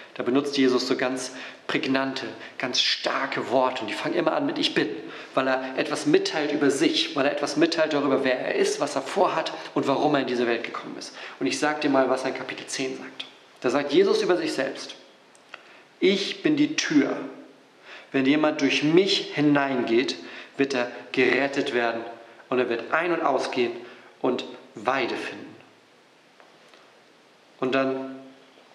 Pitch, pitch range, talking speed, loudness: 135 Hz, 130-155 Hz, 175 wpm, -24 LUFS